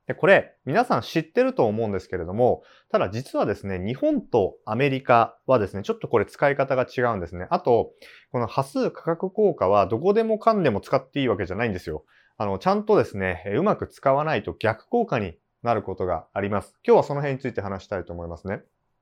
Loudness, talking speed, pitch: -24 LUFS, 430 characters per minute, 130 Hz